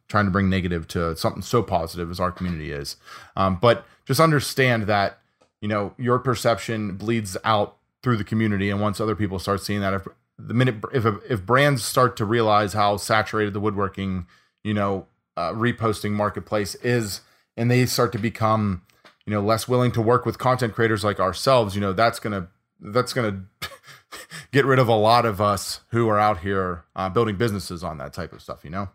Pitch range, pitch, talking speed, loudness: 95-115 Hz, 105 Hz, 195 wpm, -22 LUFS